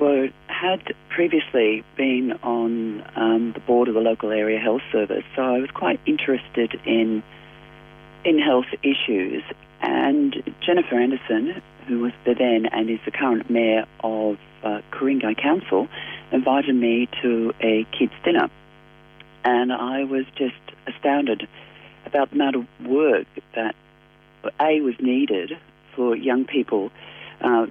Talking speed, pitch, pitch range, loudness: 135 wpm, 125 Hz, 115-140 Hz, -22 LUFS